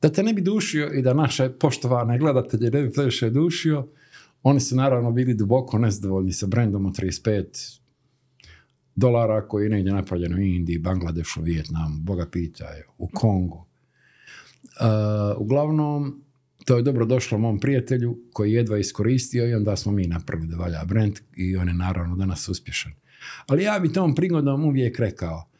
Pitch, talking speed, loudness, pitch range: 115 Hz, 165 wpm, -23 LUFS, 95-135 Hz